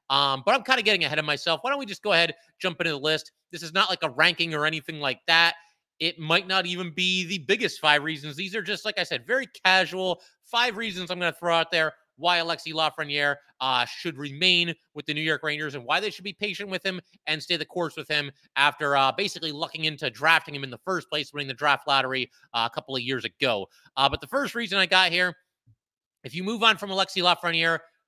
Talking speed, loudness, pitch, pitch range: 245 wpm, -24 LUFS, 165 Hz, 150-185 Hz